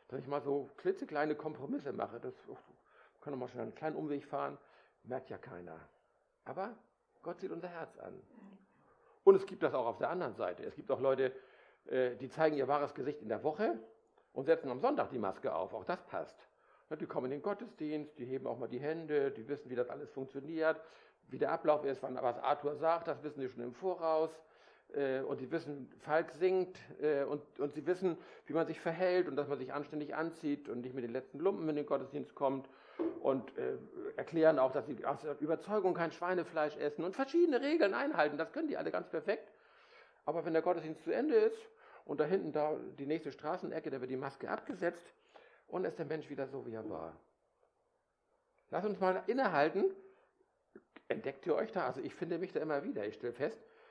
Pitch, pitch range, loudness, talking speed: 155 Hz, 140-195 Hz, -37 LUFS, 205 wpm